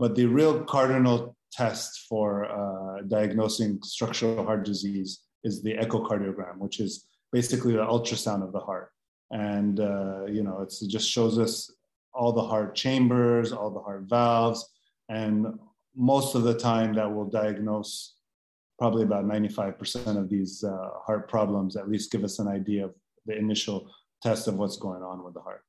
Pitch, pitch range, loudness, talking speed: 105 Hz, 100-115 Hz, -28 LUFS, 170 wpm